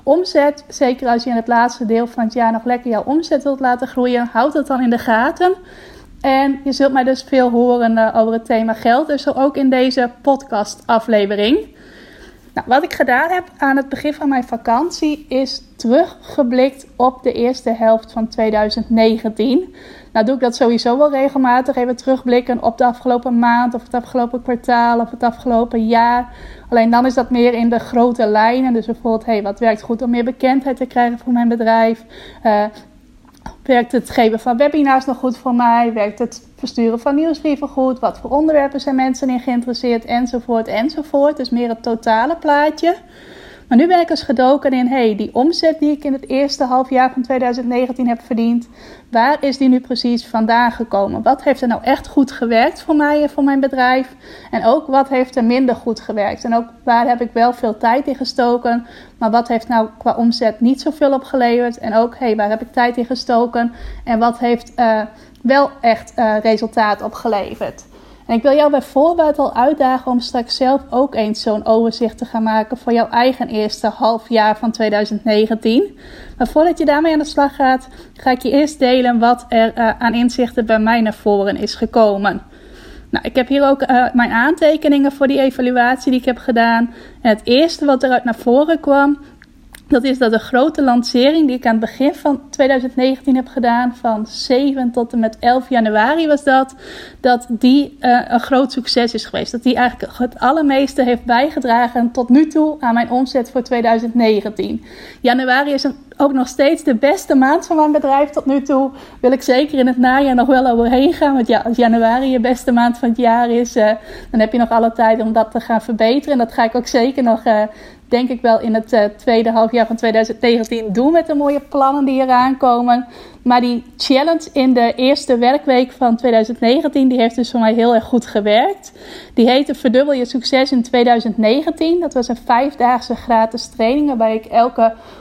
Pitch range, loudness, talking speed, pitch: 230-270 Hz, -15 LUFS, 200 wpm, 245 Hz